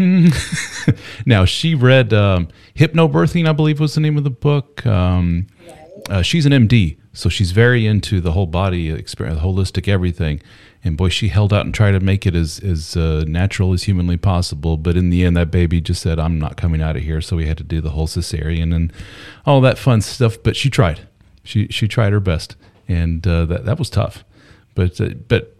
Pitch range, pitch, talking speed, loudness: 85-115 Hz, 95 Hz, 210 wpm, -17 LUFS